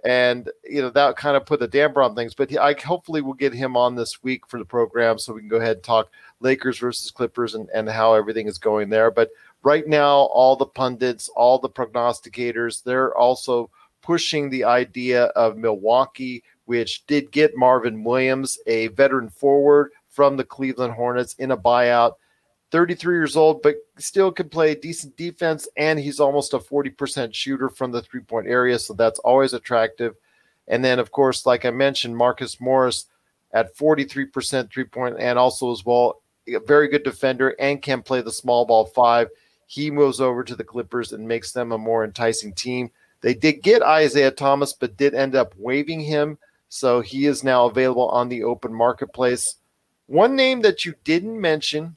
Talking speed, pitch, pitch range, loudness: 185 wpm, 130 Hz, 120-145 Hz, -20 LUFS